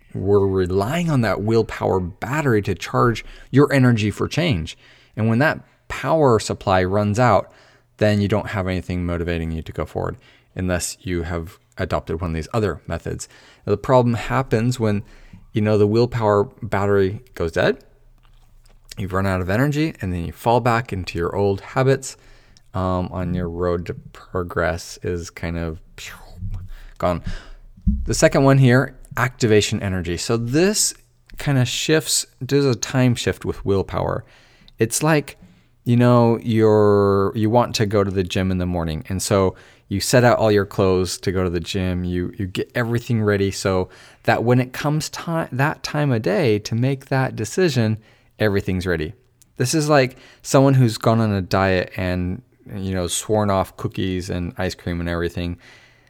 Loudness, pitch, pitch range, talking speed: -20 LUFS, 105 Hz, 95-125 Hz, 170 wpm